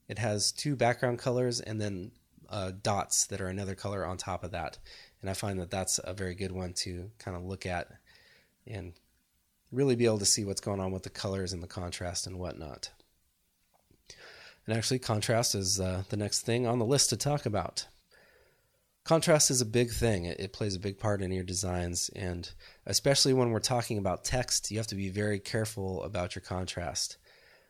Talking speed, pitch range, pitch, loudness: 200 wpm, 95-115 Hz, 100 Hz, -31 LUFS